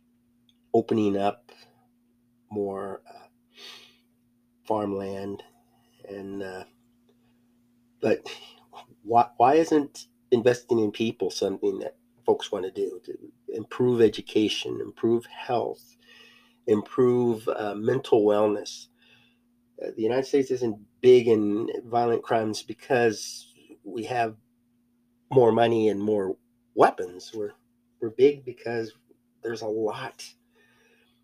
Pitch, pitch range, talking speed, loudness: 120 Hz, 110-120 Hz, 100 wpm, -25 LUFS